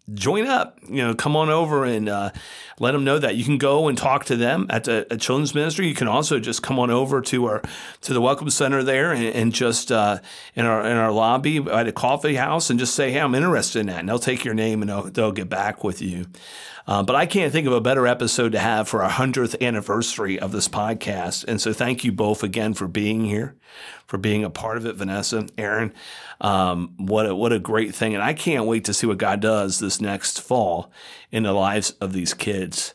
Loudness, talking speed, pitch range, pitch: -22 LUFS, 240 wpm, 105-130 Hz, 115 Hz